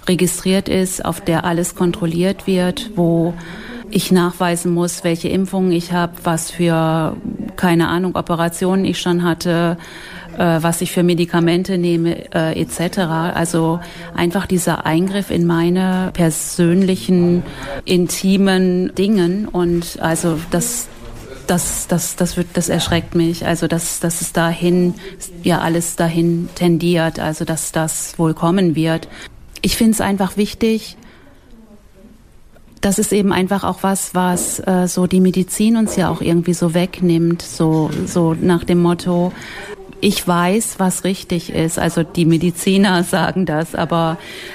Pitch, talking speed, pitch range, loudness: 175 Hz, 140 wpm, 170-185 Hz, -17 LUFS